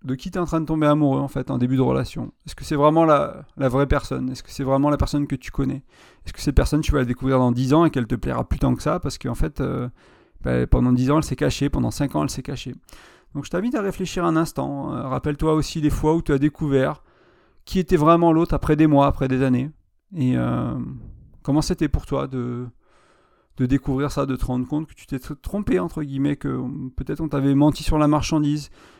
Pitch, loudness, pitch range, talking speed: 140 Hz, -22 LUFS, 130-155 Hz, 250 wpm